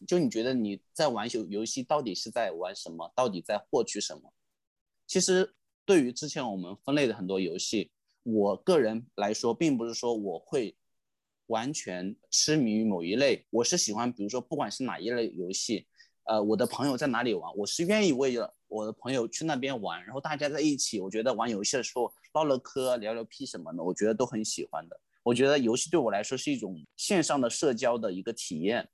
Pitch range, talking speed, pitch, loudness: 105-140 Hz, 315 characters per minute, 115 Hz, -30 LUFS